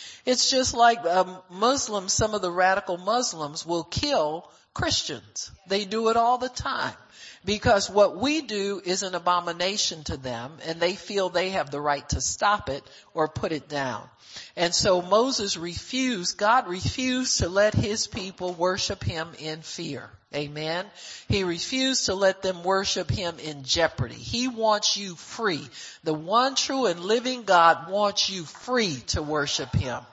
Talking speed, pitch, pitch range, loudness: 165 wpm, 185 Hz, 160-215 Hz, -25 LUFS